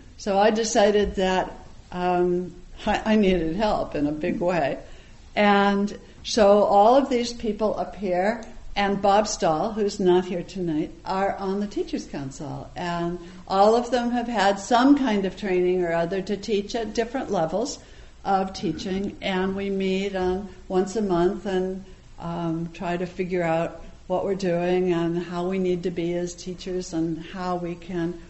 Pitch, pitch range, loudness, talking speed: 190 Hz, 175-205 Hz, -24 LUFS, 170 wpm